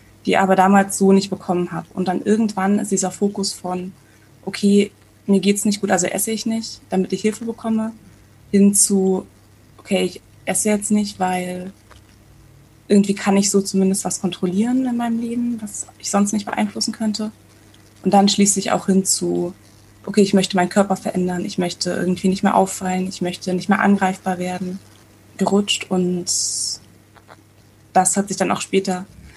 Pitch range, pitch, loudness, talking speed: 180-200 Hz, 190 Hz, -19 LUFS, 170 wpm